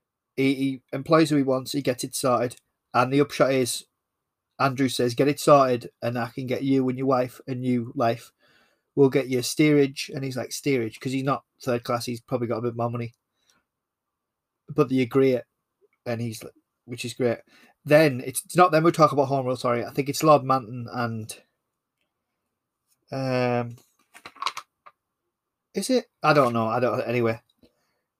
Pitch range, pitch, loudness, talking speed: 120-140 Hz, 130 Hz, -24 LUFS, 185 wpm